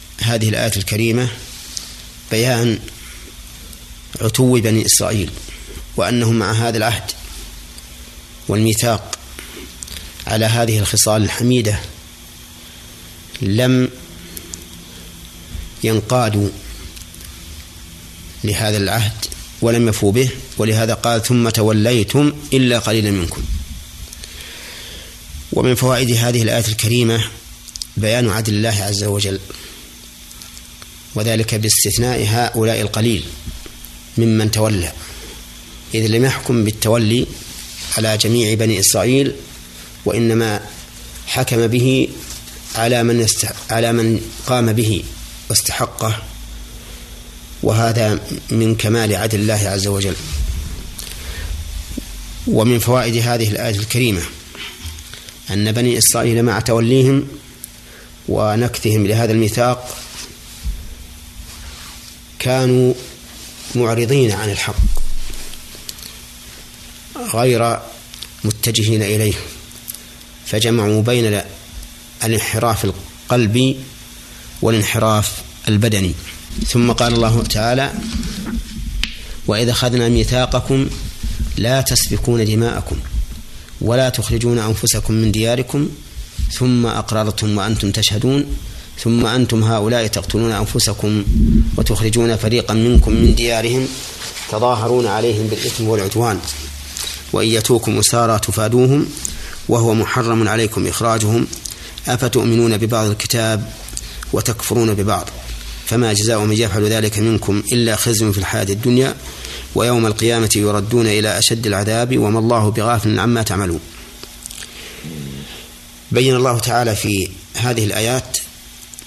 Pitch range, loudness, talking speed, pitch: 80-115 Hz, -16 LUFS, 85 wpm, 110 Hz